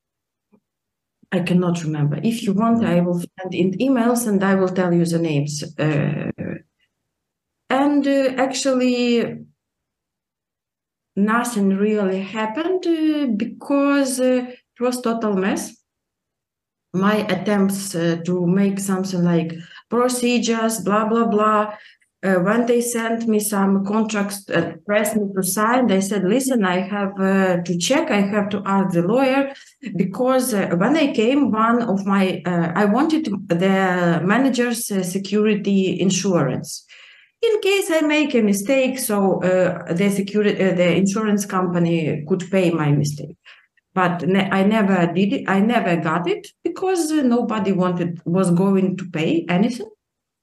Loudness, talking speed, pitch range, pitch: -19 LUFS, 145 wpm, 180-235 Hz, 200 Hz